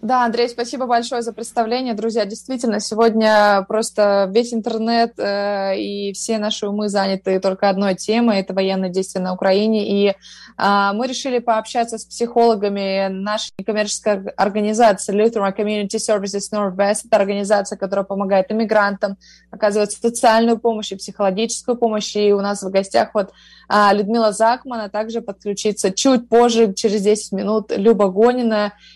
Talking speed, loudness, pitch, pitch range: 145 wpm, -18 LUFS, 210 Hz, 200-230 Hz